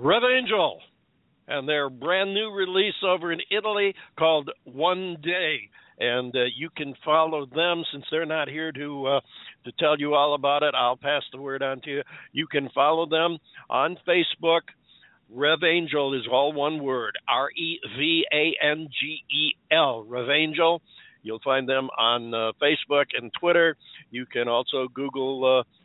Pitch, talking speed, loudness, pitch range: 150 Hz, 165 wpm, -24 LUFS, 135-165 Hz